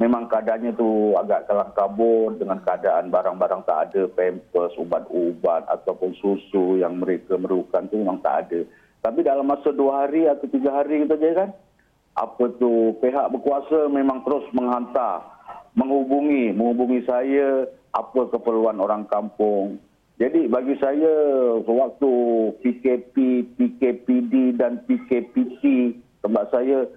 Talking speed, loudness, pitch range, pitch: 125 wpm, -22 LUFS, 110-140 Hz, 125 Hz